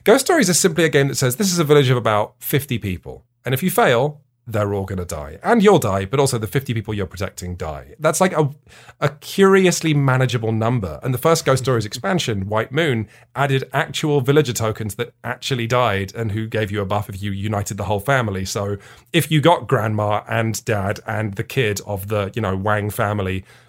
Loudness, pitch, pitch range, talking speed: -19 LUFS, 120 Hz, 105-140 Hz, 220 wpm